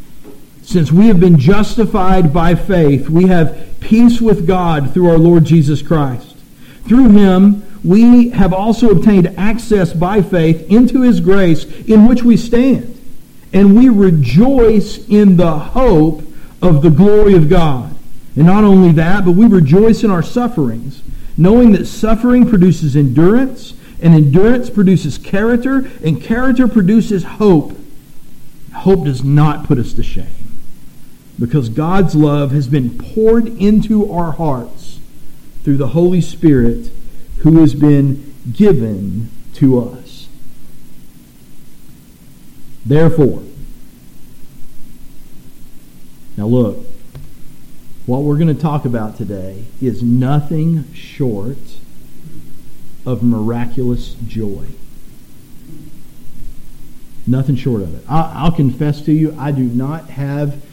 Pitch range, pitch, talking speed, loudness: 140-205 Hz, 165 Hz, 120 wpm, -11 LUFS